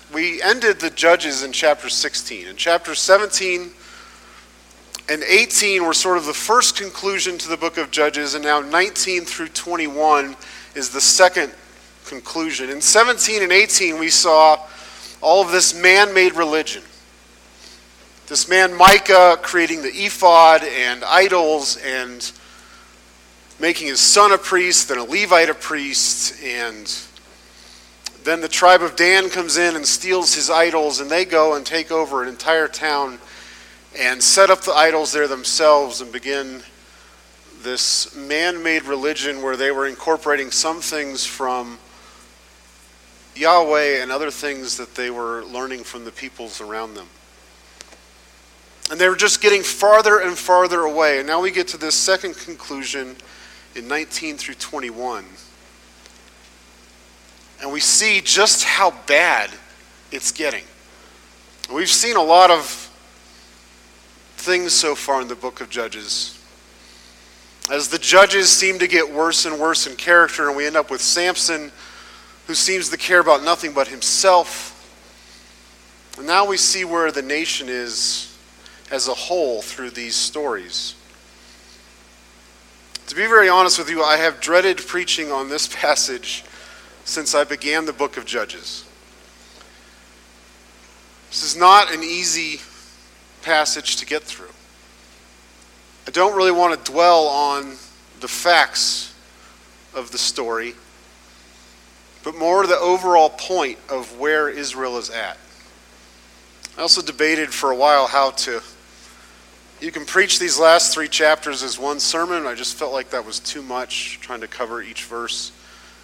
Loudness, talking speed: -16 LUFS, 145 wpm